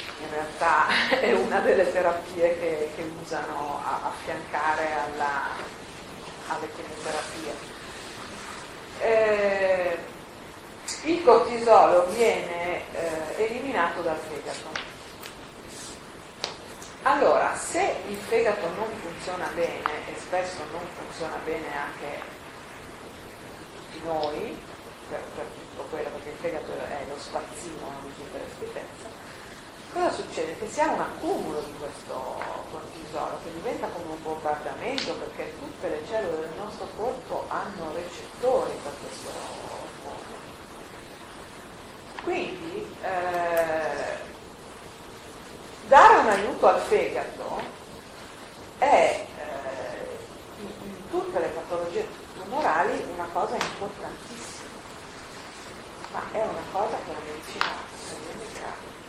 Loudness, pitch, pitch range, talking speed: -27 LUFS, 180 Hz, 165-240 Hz, 105 wpm